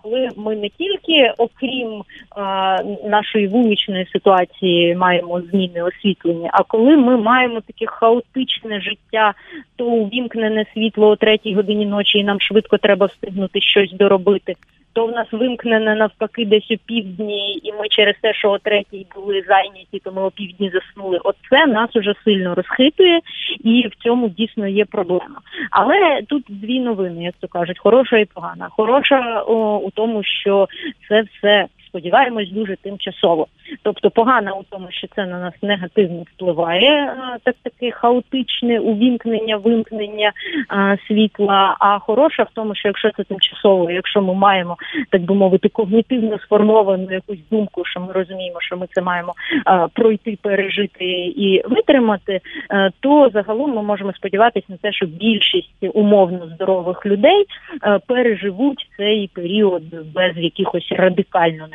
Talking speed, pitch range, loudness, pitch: 145 wpm, 195-230 Hz, -17 LUFS, 210 Hz